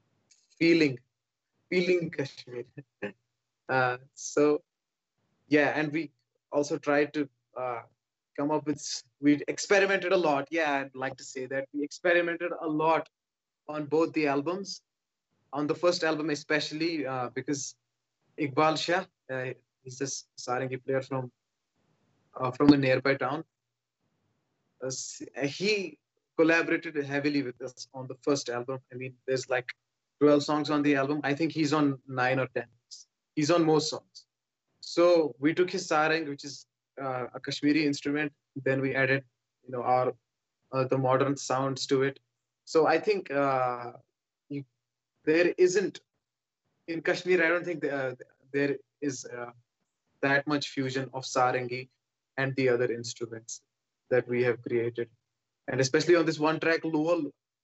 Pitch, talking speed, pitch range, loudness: 140 Hz, 150 wpm, 125-155 Hz, -29 LUFS